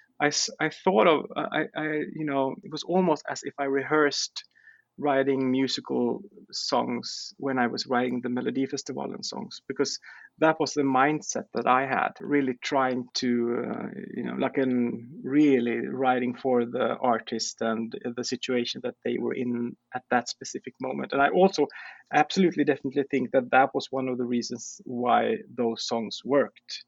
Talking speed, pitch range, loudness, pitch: 170 wpm, 125-150 Hz, -27 LUFS, 135 Hz